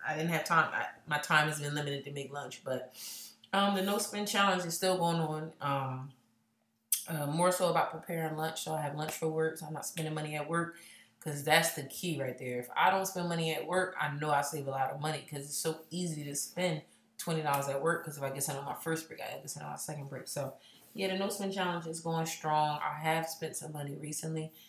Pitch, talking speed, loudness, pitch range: 155 Hz, 255 wpm, -34 LUFS, 145-165 Hz